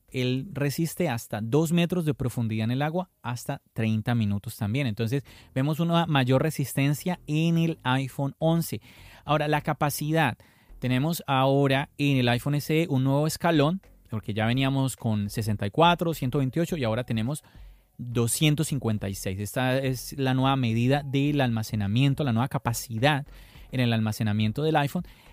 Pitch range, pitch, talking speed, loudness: 115-150 Hz, 135 Hz, 140 wpm, -26 LUFS